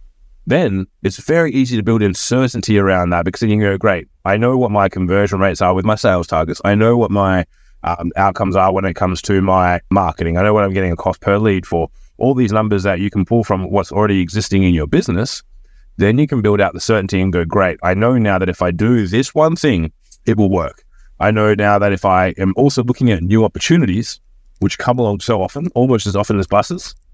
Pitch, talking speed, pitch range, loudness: 100 Hz, 240 wpm, 95-110 Hz, -15 LUFS